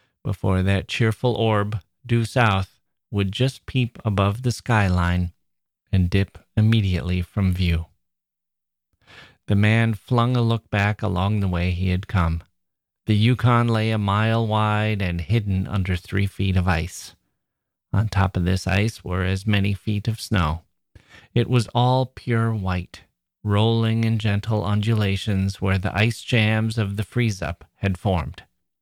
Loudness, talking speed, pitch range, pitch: -22 LUFS, 150 wpm, 95-110 Hz, 100 Hz